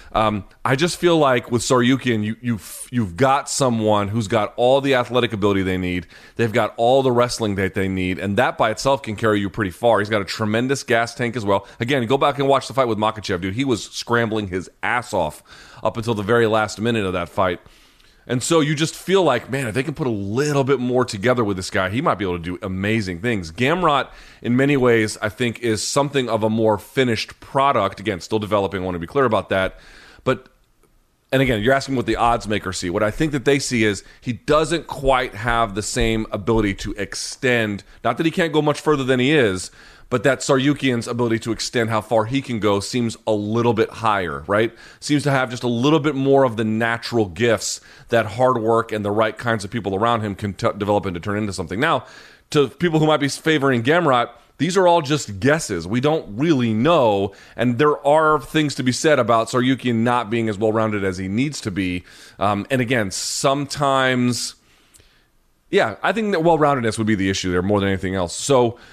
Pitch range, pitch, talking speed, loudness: 105-135 Hz, 115 Hz, 225 wpm, -20 LUFS